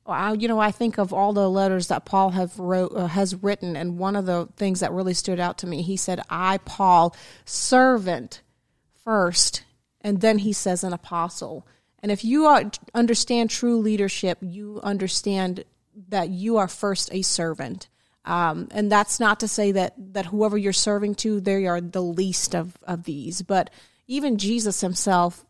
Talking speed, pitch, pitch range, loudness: 180 wpm, 195 Hz, 180-210 Hz, -23 LUFS